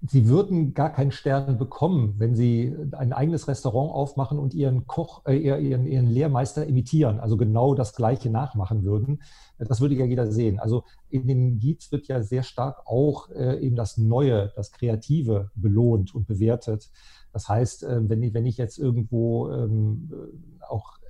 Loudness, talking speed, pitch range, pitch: -24 LUFS, 175 wpm, 115-140 Hz, 125 Hz